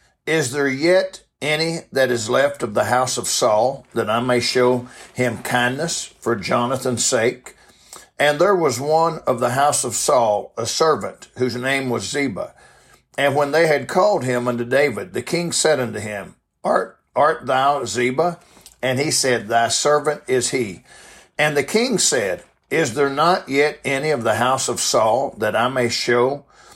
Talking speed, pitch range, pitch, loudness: 175 wpm, 125-150 Hz, 135 Hz, -19 LUFS